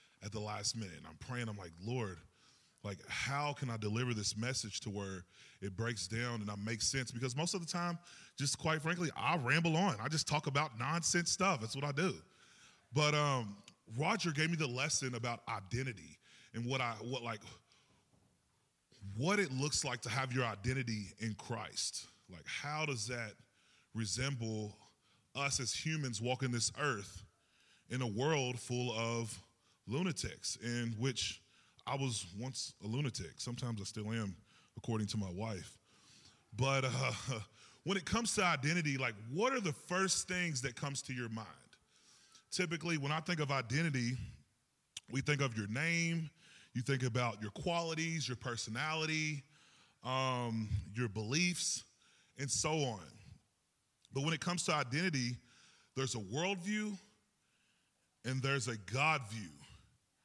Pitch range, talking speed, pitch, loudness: 110-150 Hz, 160 wpm, 125 Hz, -38 LUFS